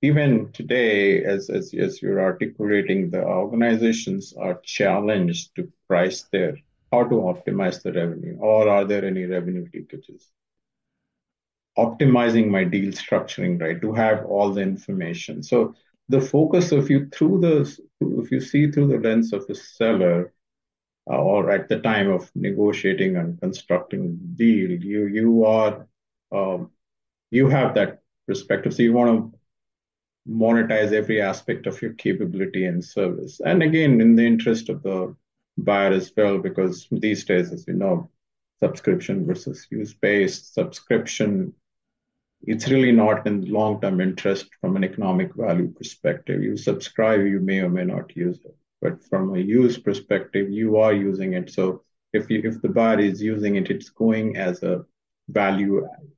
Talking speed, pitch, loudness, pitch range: 155 wpm, 110 Hz, -22 LUFS, 100-135 Hz